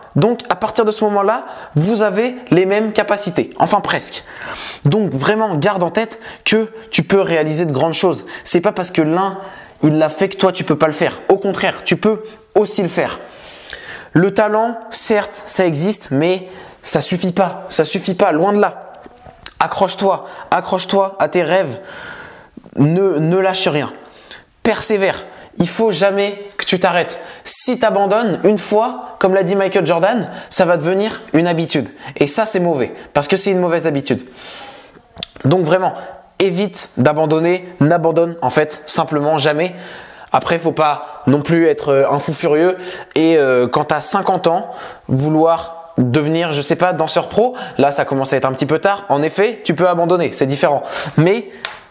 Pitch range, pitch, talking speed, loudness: 160-200 Hz, 180 Hz, 180 wpm, -16 LUFS